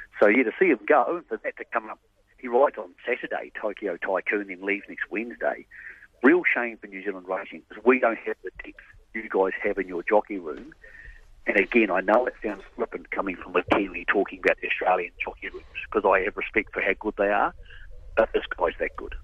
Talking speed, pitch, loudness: 220 wpm, 390 Hz, -25 LUFS